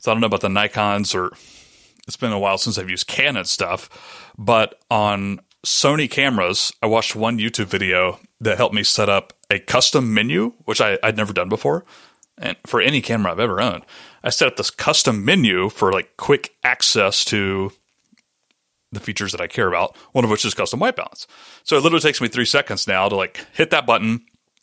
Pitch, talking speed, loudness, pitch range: 110 Hz, 205 wpm, -18 LUFS, 100-120 Hz